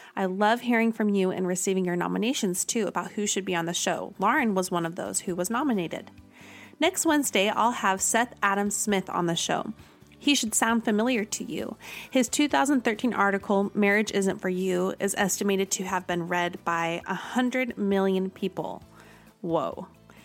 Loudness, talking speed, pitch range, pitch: -26 LUFS, 175 wpm, 185-230 Hz, 200 Hz